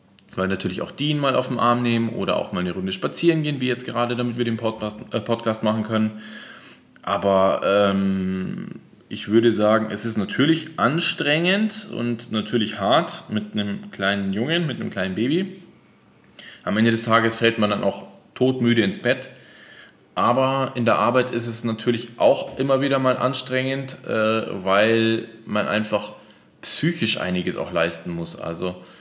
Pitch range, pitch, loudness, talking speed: 105-125 Hz, 115 Hz, -22 LUFS, 165 wpm